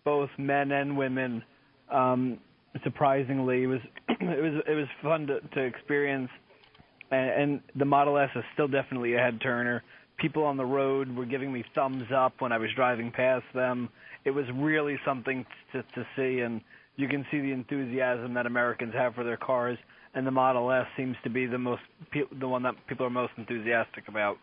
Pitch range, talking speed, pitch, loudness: 125-140 Hz, 190 wpm, 130 Hz, -29 LUFS